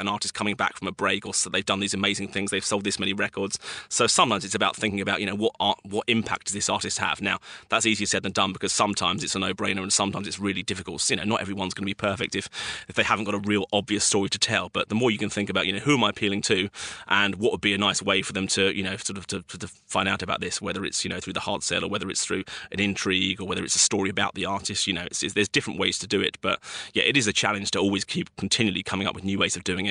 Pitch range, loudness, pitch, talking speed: 95-105 Hz, -25 LUFS, 100 Hz, 310 wpm